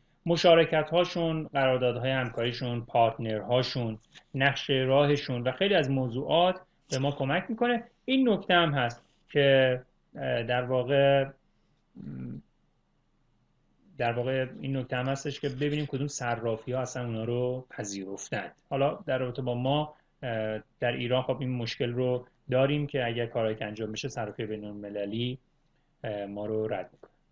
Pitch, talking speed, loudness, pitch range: 130 Hz, 140 wpm, -29 LUFS, 120-145 Hz